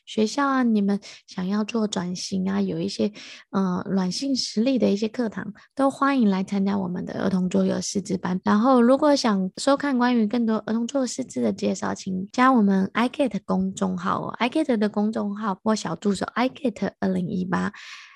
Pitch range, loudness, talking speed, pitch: 195-245 Hz, -24 LUFS, 305 characters per minute, 210 Hz